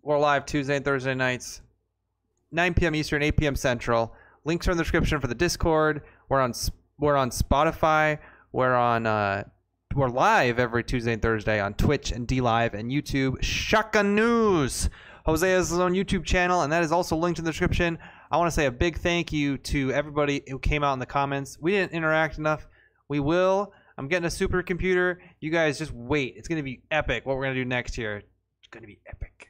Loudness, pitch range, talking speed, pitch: -25 LUFS, 120-165 Hz, 210 wpm, 145 Hz